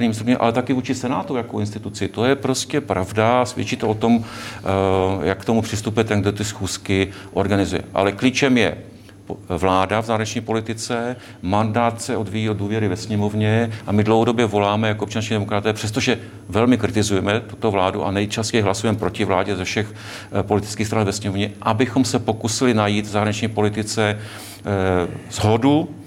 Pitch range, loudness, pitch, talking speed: 100-115 Hz, -20 LUFS, 110 Hz, 160 wpm